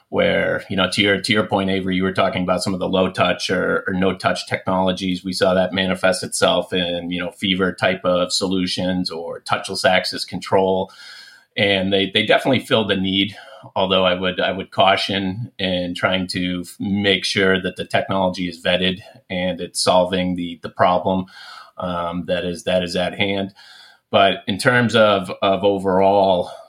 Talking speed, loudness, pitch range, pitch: 180 wpm, -19 LUFS, 90-95 Hz, 95 Hz